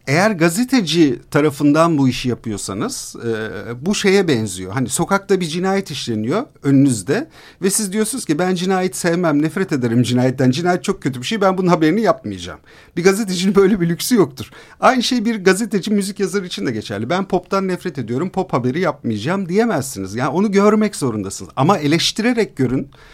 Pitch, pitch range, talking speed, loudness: 170 Hz, 130-195 Hz, 170 wpm, -17 LUFS